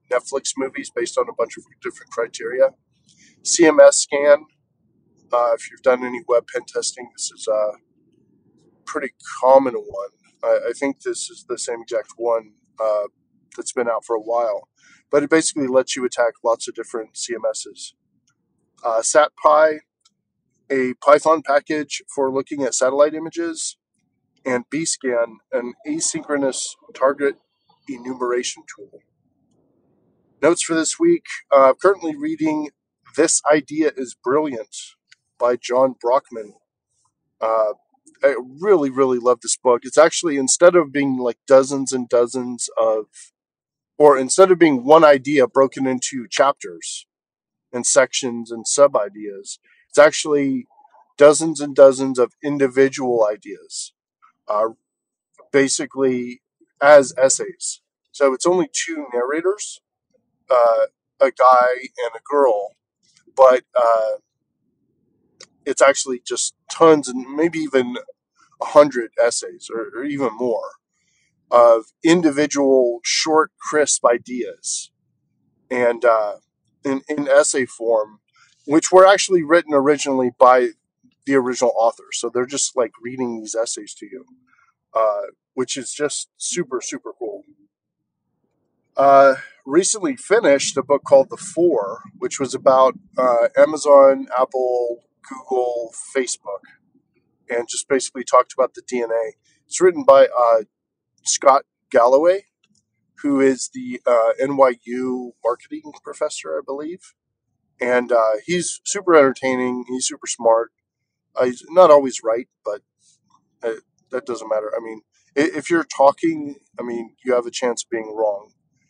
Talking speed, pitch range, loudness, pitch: 130 wpm, 125-195 Hz, -18 LUFS, 140 Hz